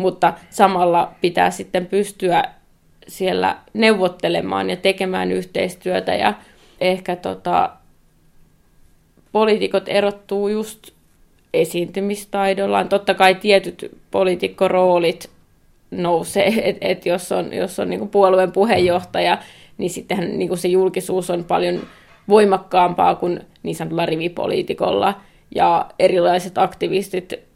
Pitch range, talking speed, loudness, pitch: 175-200 Hz, 100 wpm, -18 LUFS, 185 Hz